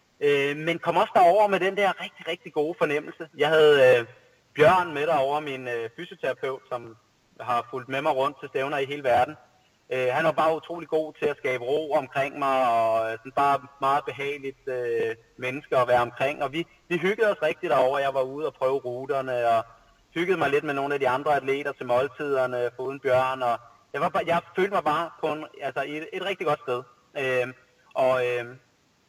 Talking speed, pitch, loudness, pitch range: 200 wpm, 140 Hz, -25 LUFS, 125-155 Hz